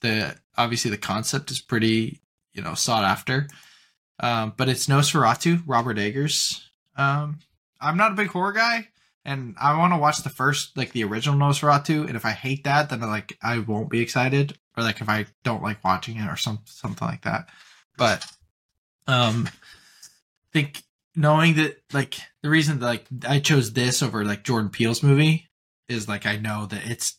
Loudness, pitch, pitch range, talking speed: -23 LUFS, 130 Hz, 115-150 Hz, 185 wpm